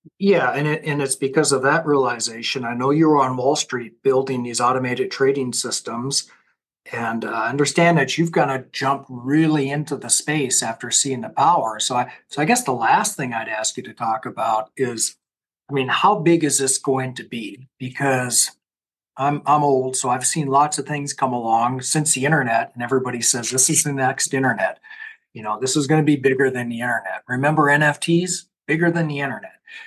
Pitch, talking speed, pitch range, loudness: 135 Hz, 205 wpm, 125-150 Hz, -19 LUFS